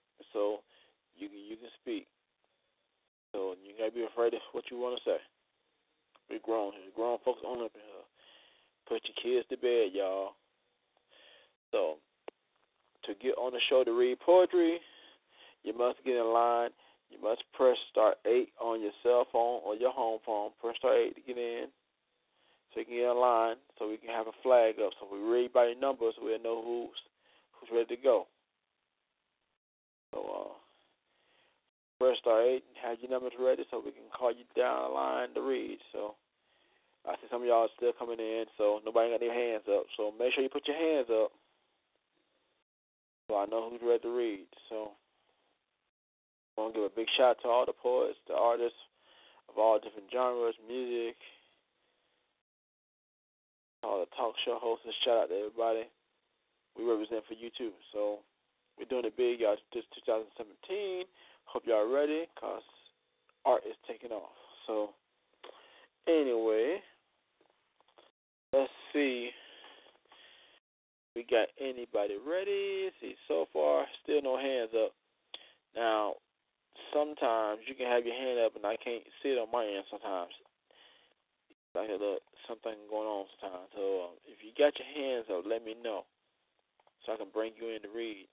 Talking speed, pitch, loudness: 170 wpm, 120 Hz, -33 LUFS